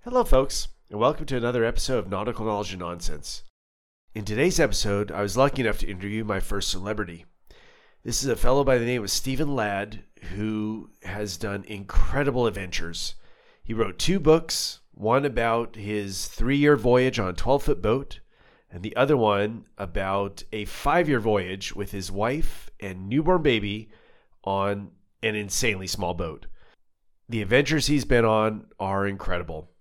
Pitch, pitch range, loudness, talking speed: 105 Hz, 95-120 Hz, -25 LUFS, 165 wpm